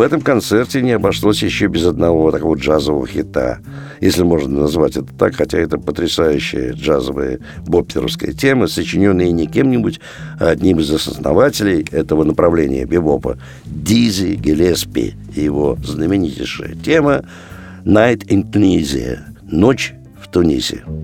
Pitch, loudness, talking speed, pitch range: 90 Hz, -15 LUFS, 125 wpm, 80-110 Hz